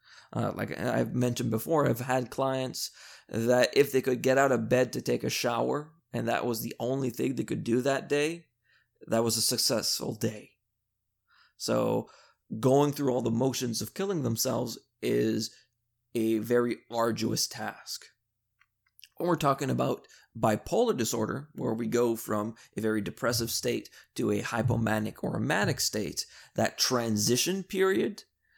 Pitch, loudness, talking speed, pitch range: 120 Hz, -29 LUFS, 155 wpm, 115-130 Hz